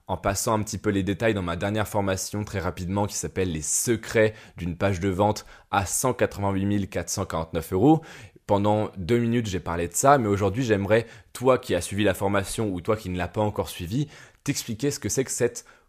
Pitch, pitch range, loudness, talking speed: 100 Hz, 95-115 Hz, -25 LUFS, 210 wpm